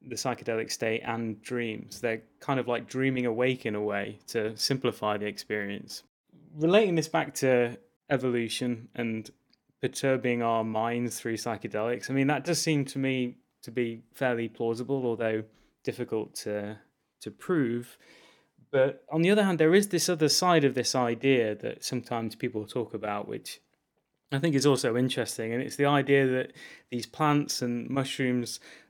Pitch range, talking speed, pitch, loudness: 115-135 Hz, 160 wpm, 125 Hz, -29 LUFS